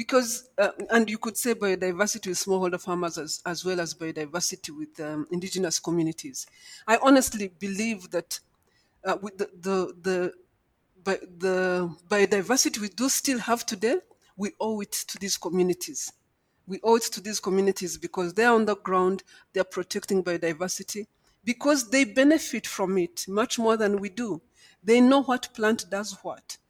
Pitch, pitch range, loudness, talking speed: 200 Hz, 180-230 Hz, -26 LUFS, 165 wpm